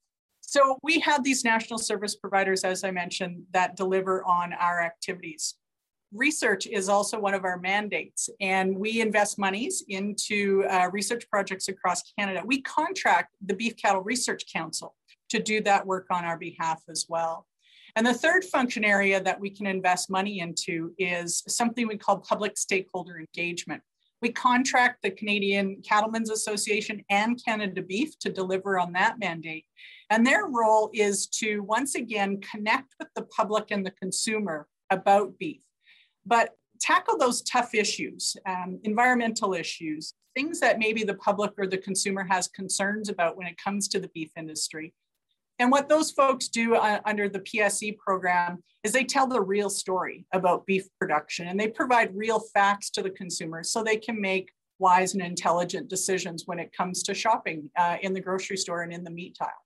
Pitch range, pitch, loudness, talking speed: 185-220 Hz, 200 Hz, -26 LUFS, 175 wpm